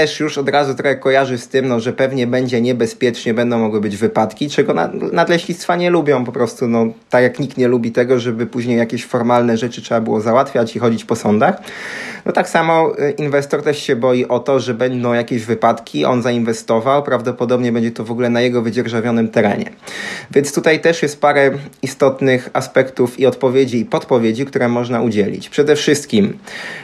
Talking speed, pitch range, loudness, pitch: 185 wpm, 120-140 Hz, -16 LUFS, 125 Hz